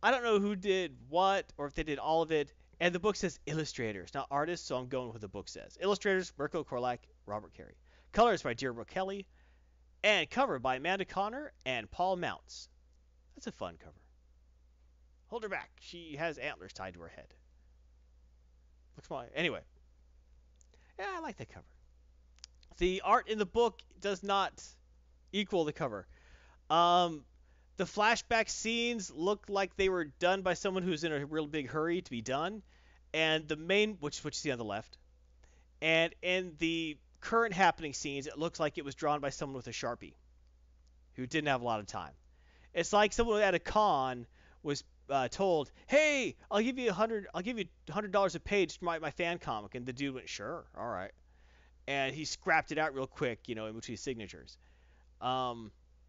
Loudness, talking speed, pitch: -34 LUFS, 195 wpm, 140 Hz